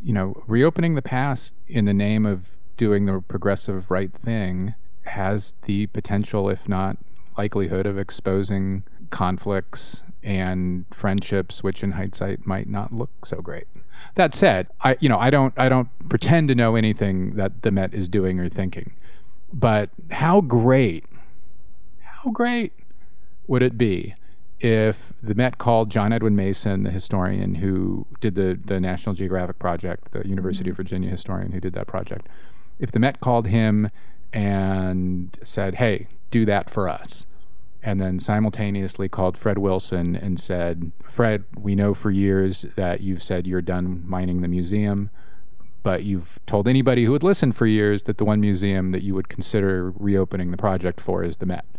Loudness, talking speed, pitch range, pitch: -23 LUFS, 165 wpm, 95-110 Hz, 100 Hz